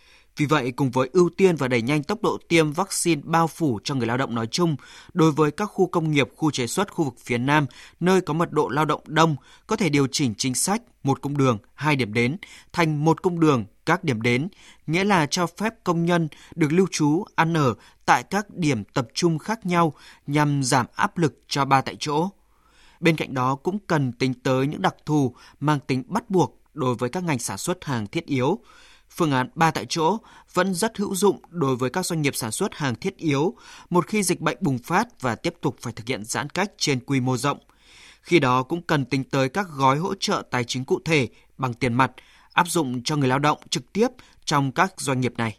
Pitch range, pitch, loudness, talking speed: 130-175 Hz, 150 Hz, -23 LUFS, 230 wpm